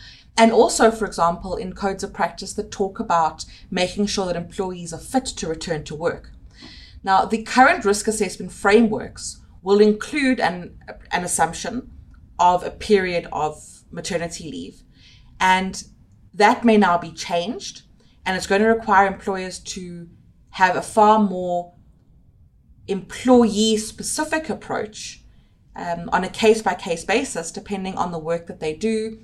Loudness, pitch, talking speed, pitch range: -20 LUFS, 195 Hz, 150 wpm, 170-215 Hz